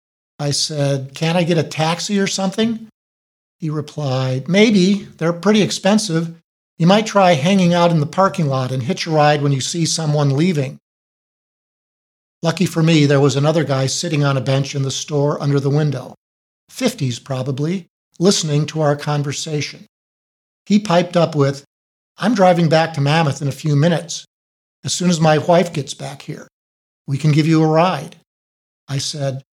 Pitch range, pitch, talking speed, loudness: 140-175 Hz, 155 Hz, 170 wpm, -17 LUFS